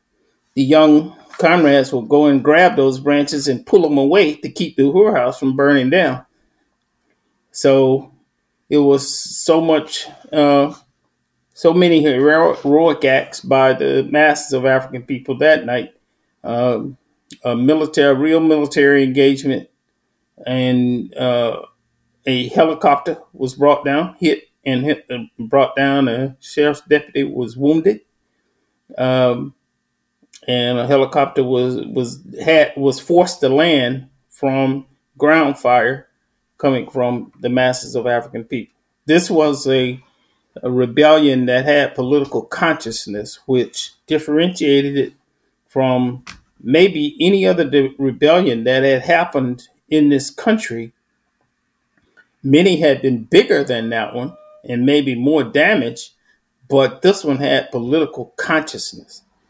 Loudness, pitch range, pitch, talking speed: -15 LUFS, 125-150 Hz, 140 Hz, 125 wpm